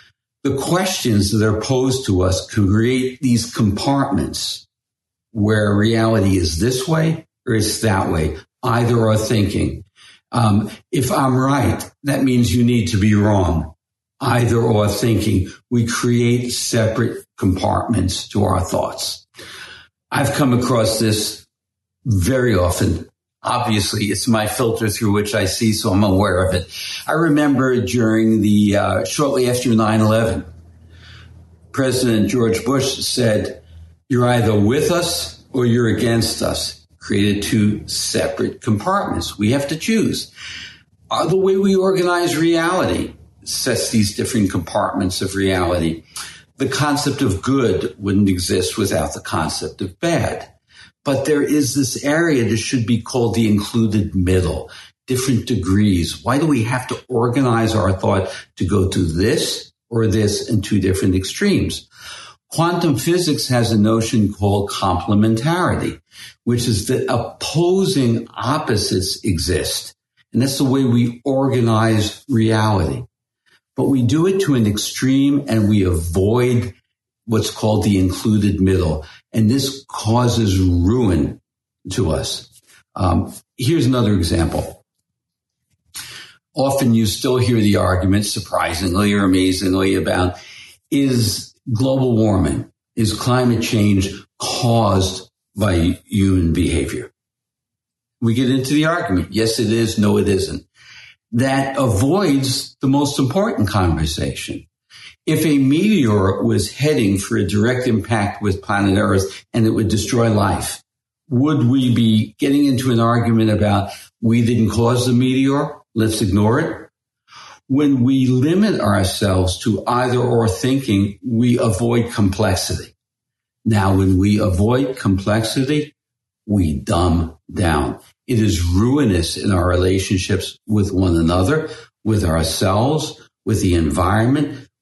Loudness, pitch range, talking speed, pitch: -17 LUFS, 100-125 Hz, 130 wpm, 110 Hz